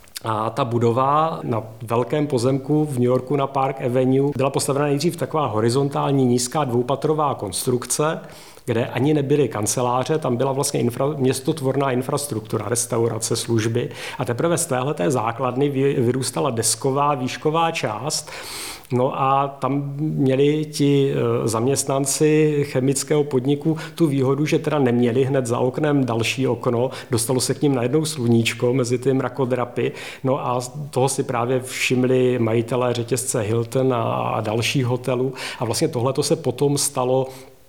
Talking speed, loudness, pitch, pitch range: 135 wpm, -21 LUFS, 130 Hz, 125-145 Hz